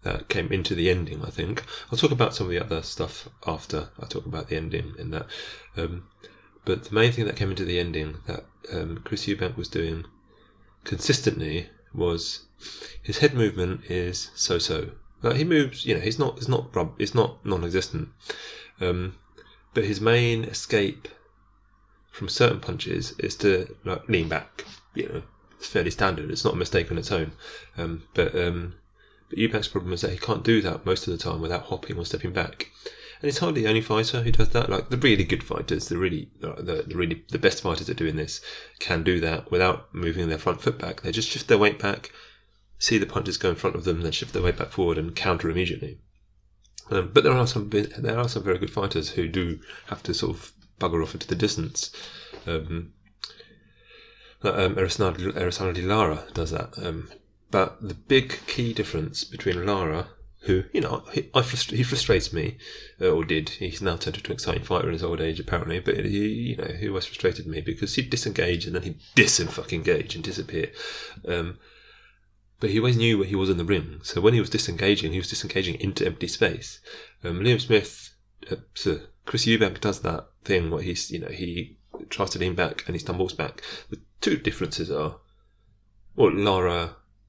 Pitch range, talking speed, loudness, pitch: 85-110 Hz, 205 wpm, -26 LUFS, 95 Hz